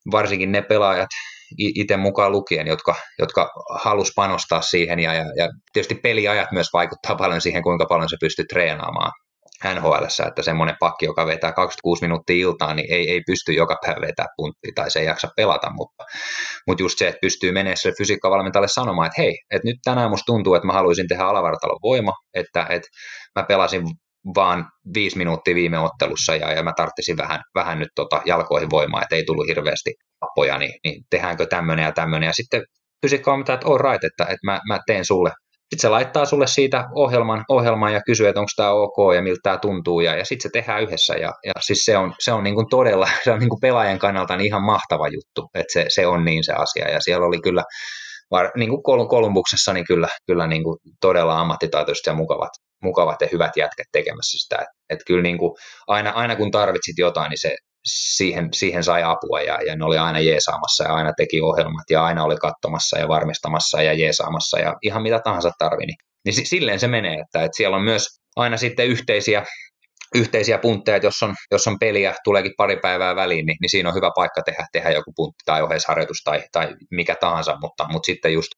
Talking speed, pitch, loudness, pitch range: 205 wpm, 100 Hz, -20 LUFS, 85-120 Hz